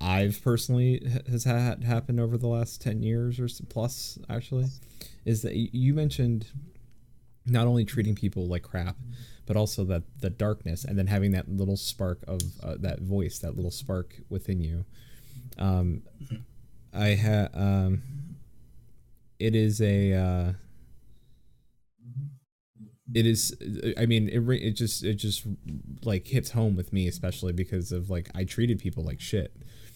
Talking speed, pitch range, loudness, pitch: 150 wpm, 95-120 Hz, -29 LUFS, 110 Hz